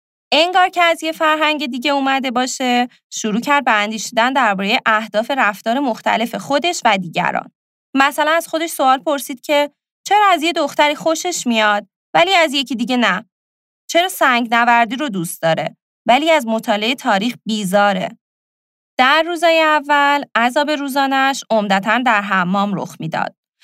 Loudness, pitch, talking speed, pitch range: -16 LUFS, 260 Hz, 145 wpm, 220-300 Hz